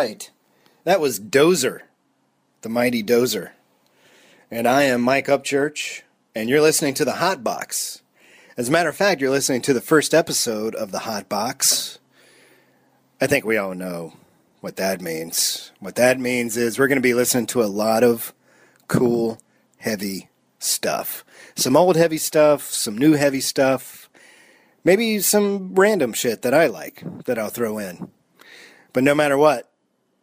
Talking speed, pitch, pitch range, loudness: 160 wpm, 135 Hz, 120-155 Hz, -20 LUFS